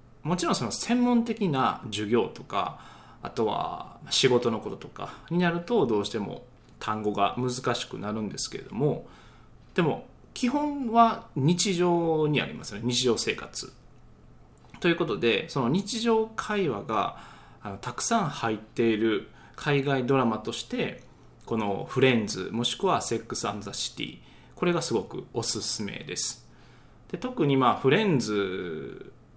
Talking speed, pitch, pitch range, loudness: 280 characters per minute, 135 Hz, 115-195 Hz, -27 LUFS